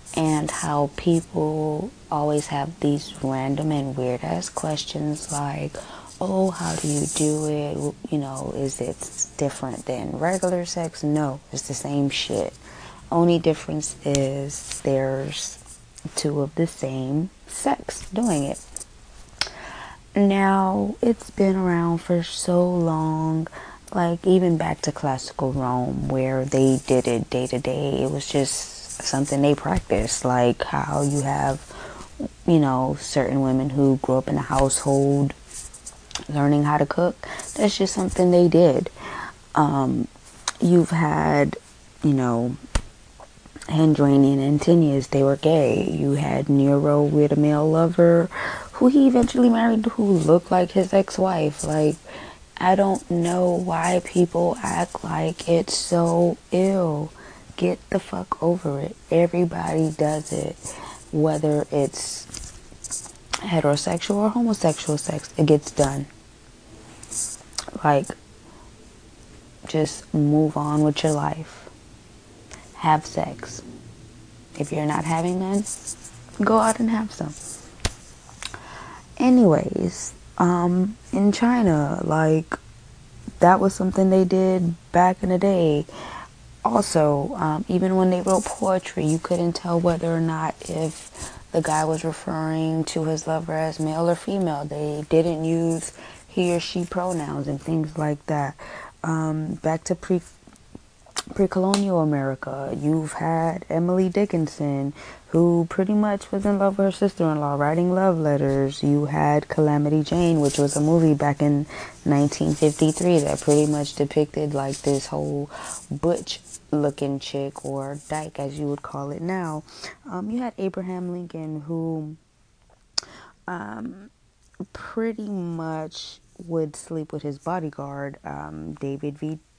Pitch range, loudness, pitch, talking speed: 145-175 Hz, -22 LUFS, 155 Hz, 130 wpm